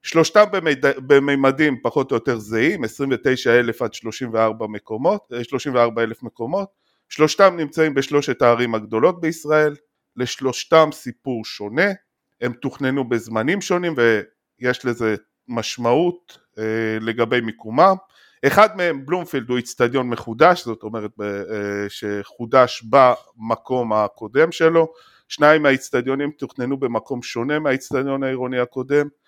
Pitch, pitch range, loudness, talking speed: 130 Hz, 115-150 Hz, -19 LUFS, 105 wpm